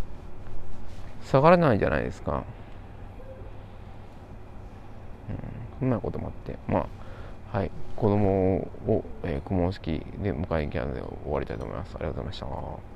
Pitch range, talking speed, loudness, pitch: 90-105 Hz, 295 characters per minute, -28 LUFS, 100 Hz